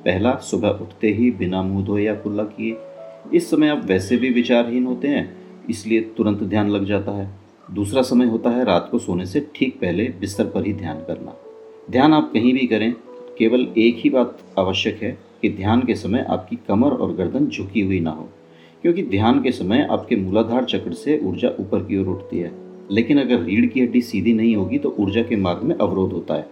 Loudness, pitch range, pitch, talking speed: -20 LUFS, 100-125 Hz, 110 Hz, 210 wpm